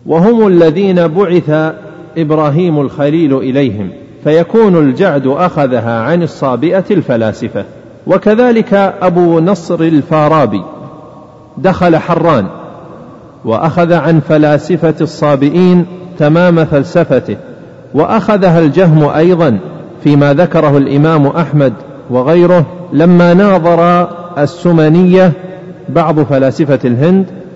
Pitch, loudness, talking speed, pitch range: 165 Hz, -9 LUFS, 85 wpm, 150-180 Hz